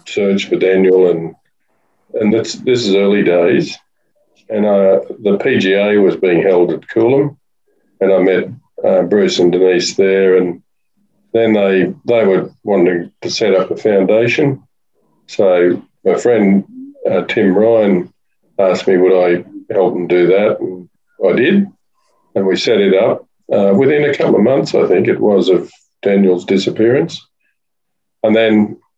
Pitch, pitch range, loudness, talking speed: 100 Hz, 90-145 Hz, -13 LUFS, 155 wpm